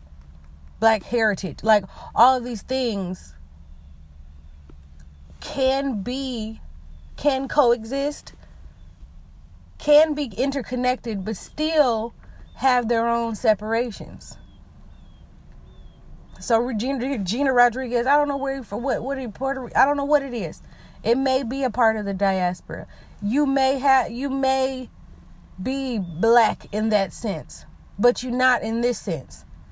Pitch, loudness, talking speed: 230 Hz, -22 LUFS, 135 wpm